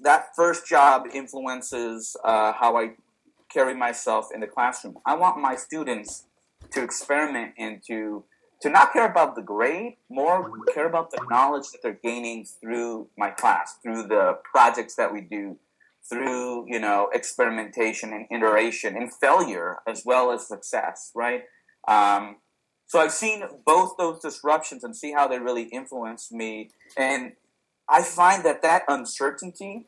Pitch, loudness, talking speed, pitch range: 120 Hz, -23 LUFS, 155 wpm, 115-160 Hz